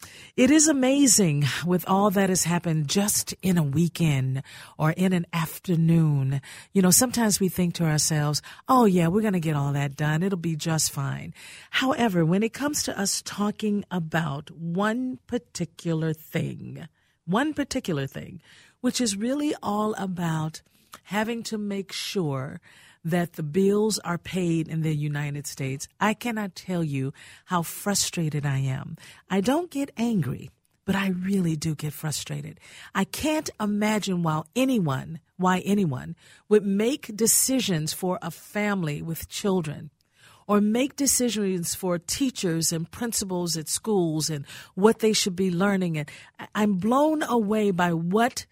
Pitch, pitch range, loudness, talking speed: 180 Hz, 160-210 Hz, -25 LUFS, 150 wpm